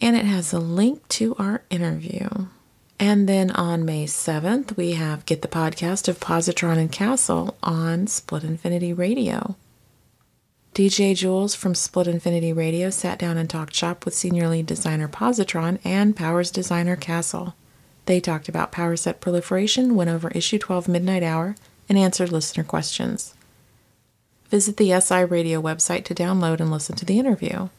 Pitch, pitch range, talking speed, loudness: 175 Hz, 165-195 Hz, 160 wpm, -22 LUFS